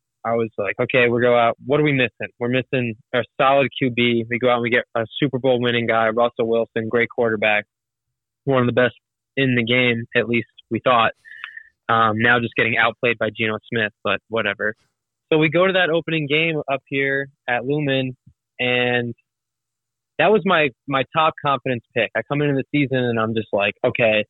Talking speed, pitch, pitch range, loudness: 200 wpm, 120 Hz, 115-135 Hz, -20 LUFS